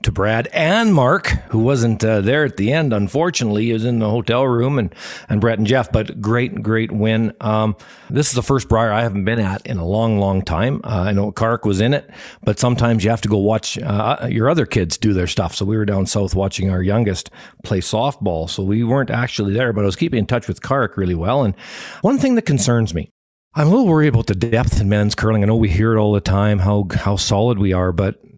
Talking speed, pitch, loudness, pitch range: 245 wpm, 110 Hz, -17 LUFS, 100-120 Hz